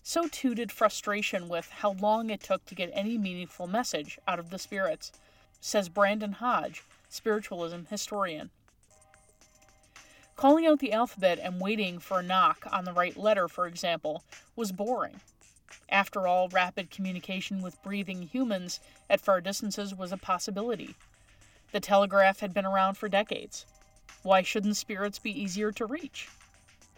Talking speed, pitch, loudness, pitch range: 150 wpm, 195 Hz, -30 LUFS, 180-215 Hz